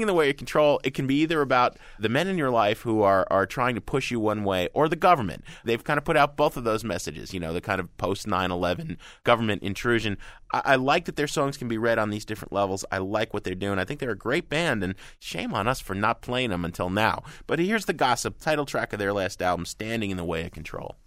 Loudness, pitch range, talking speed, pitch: -26 LUFS, 95-140 Hz, 275 wpm, 110 Hz